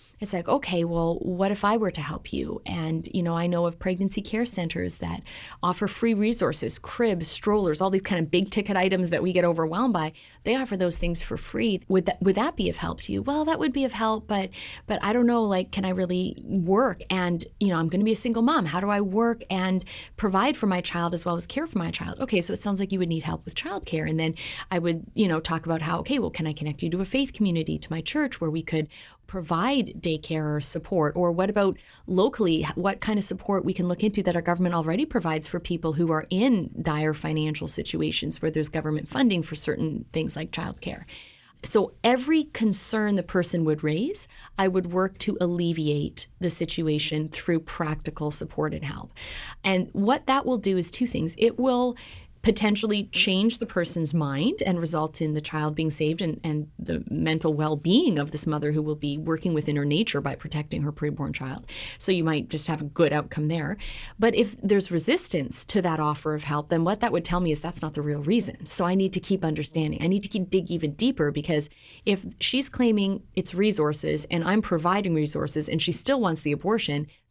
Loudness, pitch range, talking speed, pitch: -25 LUFS, 160-205 Hz, 225 wpm, 180 Hz